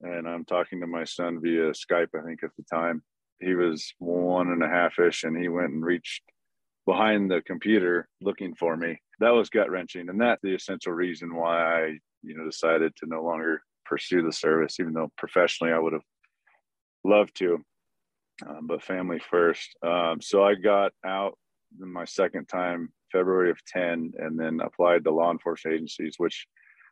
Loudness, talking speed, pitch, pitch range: -26 LUFS, 185 wpm, 85 Hz, 80-90 Hz